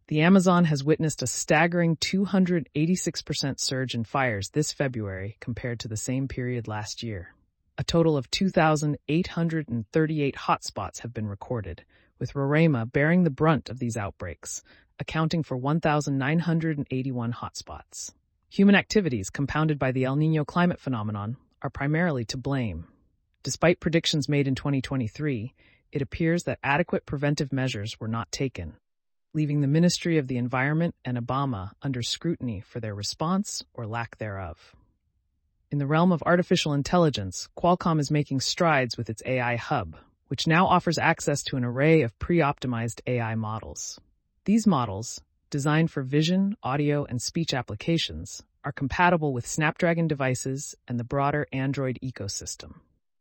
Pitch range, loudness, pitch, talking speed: 120-160 Hz, -26 LUFS, 140 Hz, 145 wpm